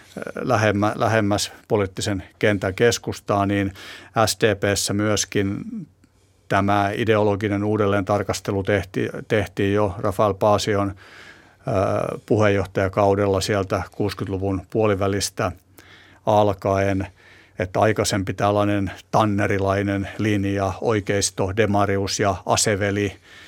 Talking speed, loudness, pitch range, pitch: 80 wpm, -21 LUFS, 100-105 Hz, 100 Hz